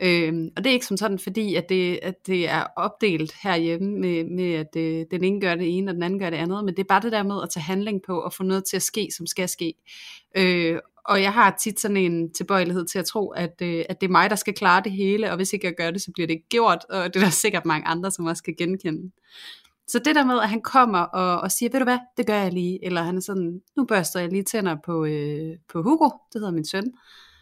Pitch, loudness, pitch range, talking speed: 185 Hz, -23 LUFS, 170-205 Hz, 280 wpm